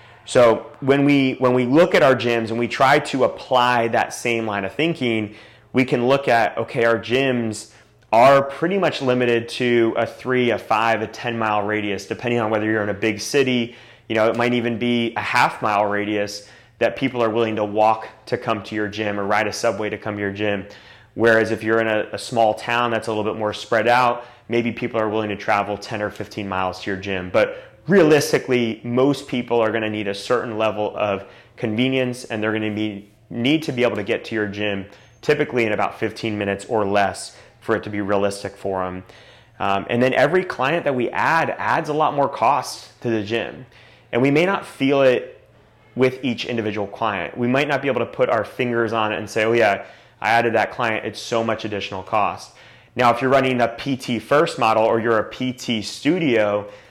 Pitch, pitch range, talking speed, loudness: 115 Hz, 105-125 Hz, 220 wpm, -20 LUFS